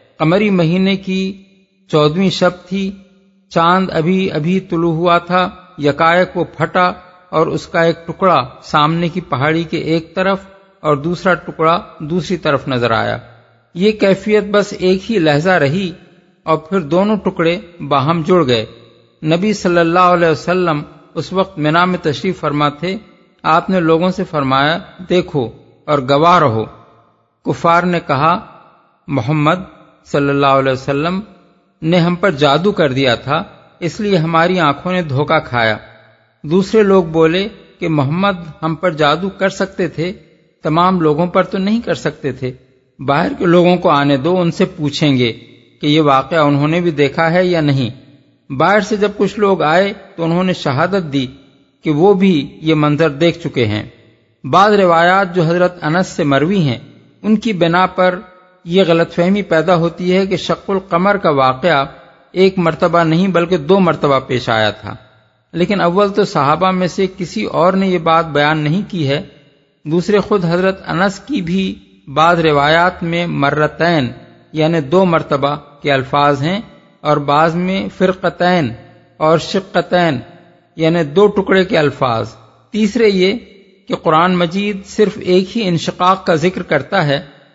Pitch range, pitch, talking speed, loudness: 150-185 Hz, 170 Hz, 160 wpm, -14 LUFS